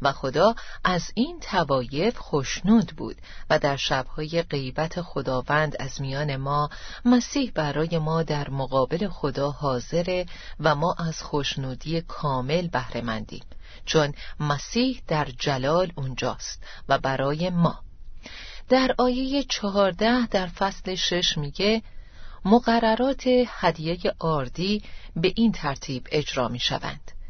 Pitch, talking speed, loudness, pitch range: 160 Hz, 115 wpm, -25 LUFS, 140-195 Hz